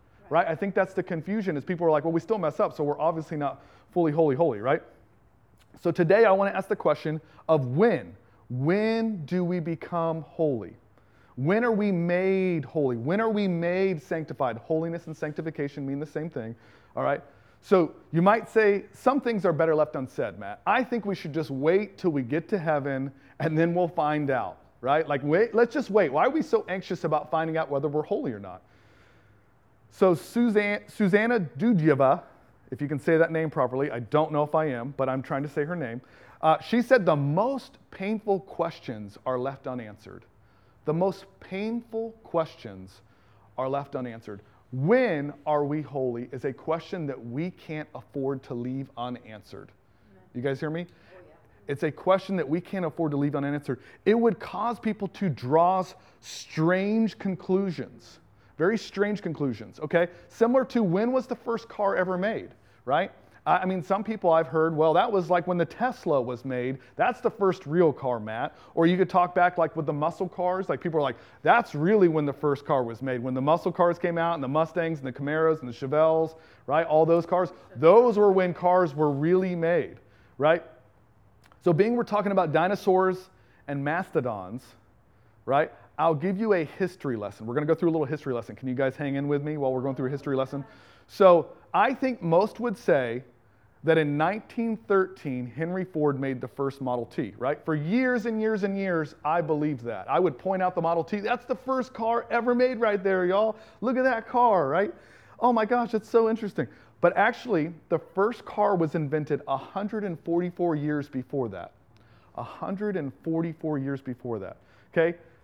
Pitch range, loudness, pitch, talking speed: 135-190 Hz, -26 LUFS, 160 Hz, 190 wpm